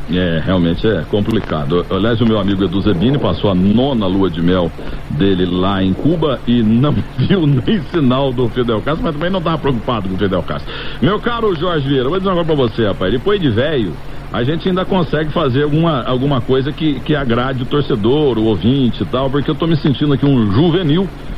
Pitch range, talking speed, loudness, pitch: 100-150 Hz, 210 wpm, -15 LUFS, 125 Hz